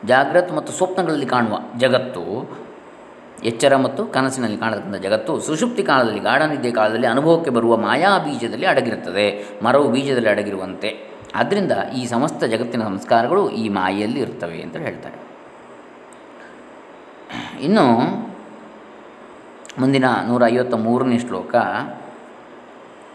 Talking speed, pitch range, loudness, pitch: 100 wpm, 115-130 Hz, -19 LUFS, 125 Hz